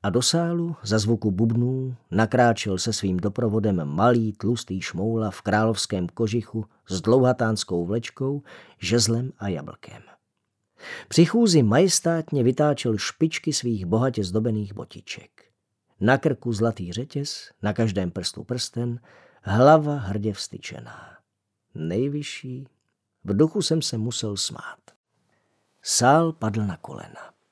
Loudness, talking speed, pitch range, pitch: -23 LUFS, 115 wpm, 105-130 Hz, 115 Hz